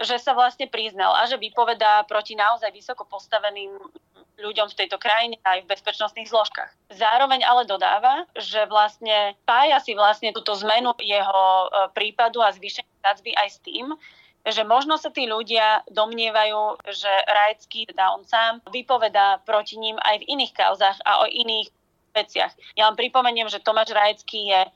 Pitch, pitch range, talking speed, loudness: 215 Hz, 205-230 Hz, 160 wpm, -21 LUFS